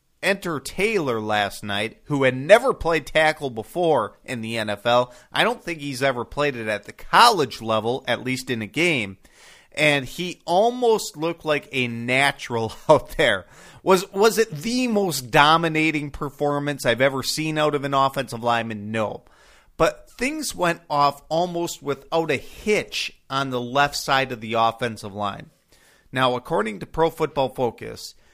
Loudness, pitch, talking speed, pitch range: -22 LUFS, 140 Hz, 160 wpm, 120-165 Hz